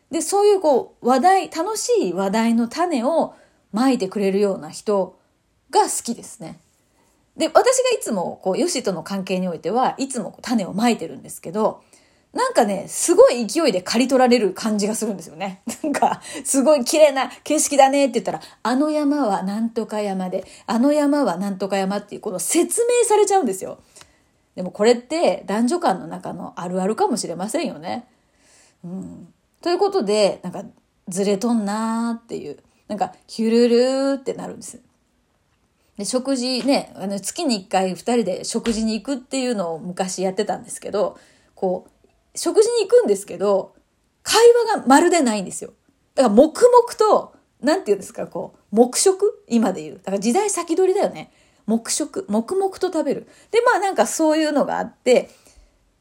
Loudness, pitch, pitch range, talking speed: -20 LUFS, 250 Hz, 205-320 Hz, 345 characters per minute